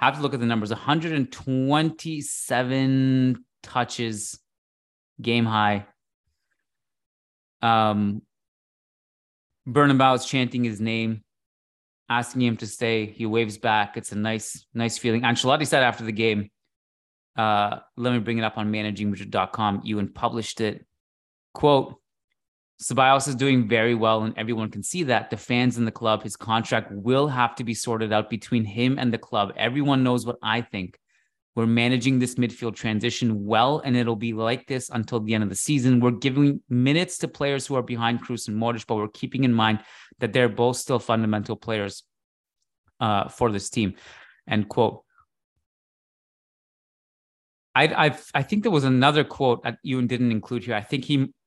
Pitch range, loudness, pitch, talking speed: 105-125 Hz, -24 LUFS, 115 Hz, 165 wpm